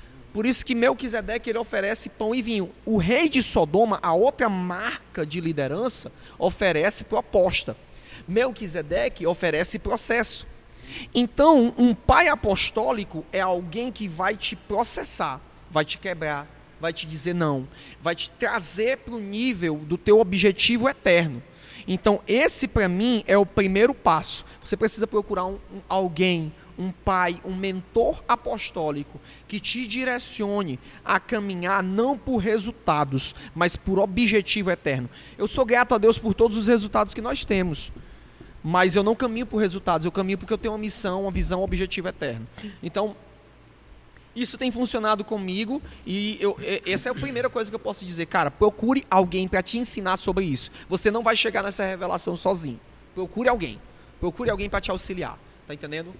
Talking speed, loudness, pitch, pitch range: 160 wpm, -24 LUFS, 200 Hz, 175-230 Hz